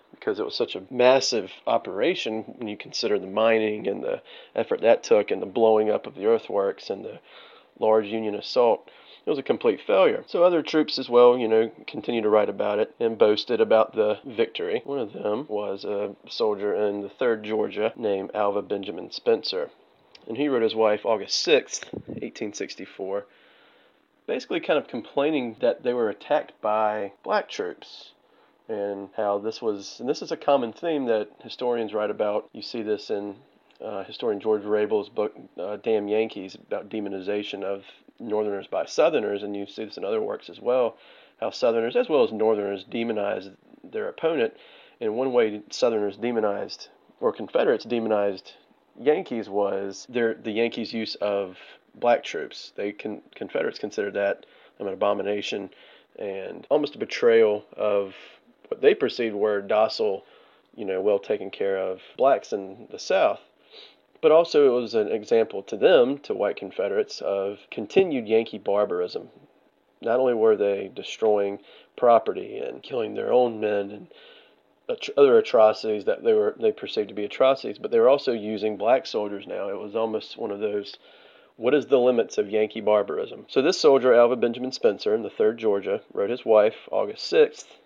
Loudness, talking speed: -24 LUFS, 170 wpm